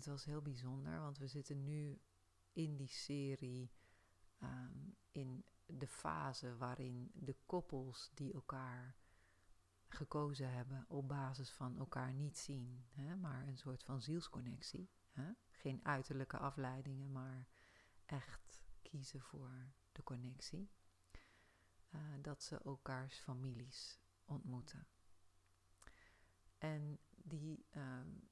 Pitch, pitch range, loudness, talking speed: 130 Hz, 95-140 Hz, -50 LUFS, 110 wpm